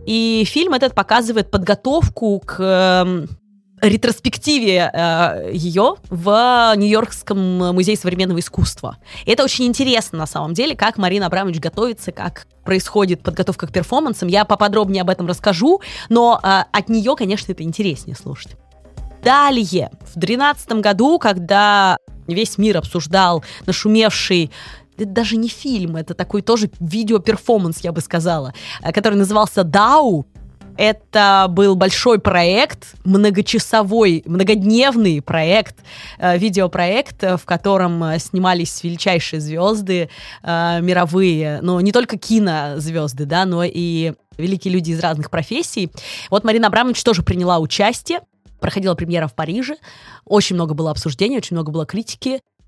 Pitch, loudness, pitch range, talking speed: 195 Hz, -16 LUFS, 175-220 Hz, 125 wpm